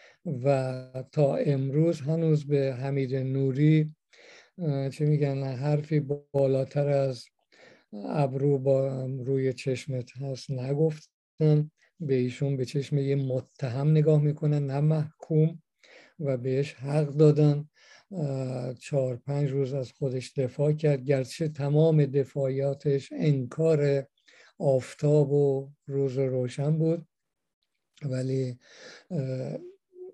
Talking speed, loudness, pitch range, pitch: 100 wpm, -27 LUFS, 135-150 Hz, 140 Hz